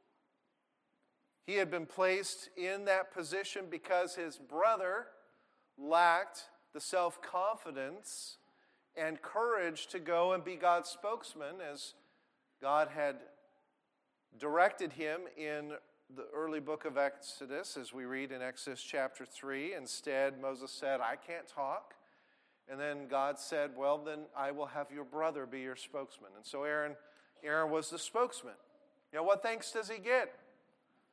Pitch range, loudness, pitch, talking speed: 145-200 Hz, -37 LUFS, 160 Hz, 140 wpm